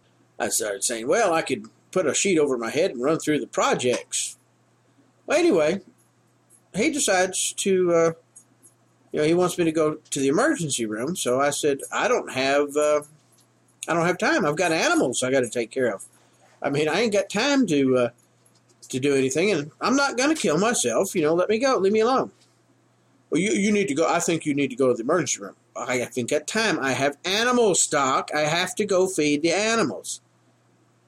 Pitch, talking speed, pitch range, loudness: 155 Hz, 215 wpm, 140-195 Hz, -23 LUFS